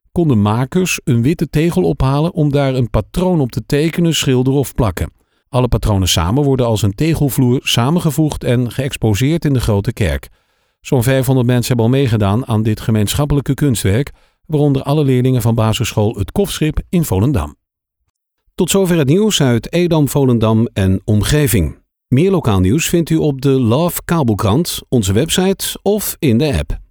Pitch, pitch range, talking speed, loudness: 135 Hz, 115-155 Hz, 165 wpm, -15 LUFS